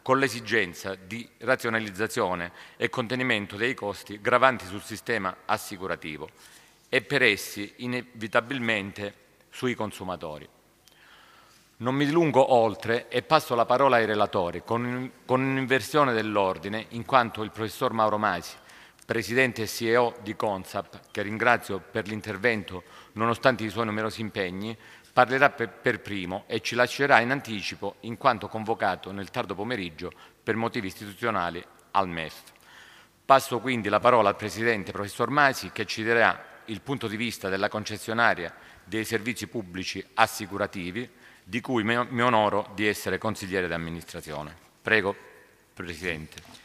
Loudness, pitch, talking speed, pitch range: -26 LUFS, 110 Hz, 130 wpm, 100-120 Hz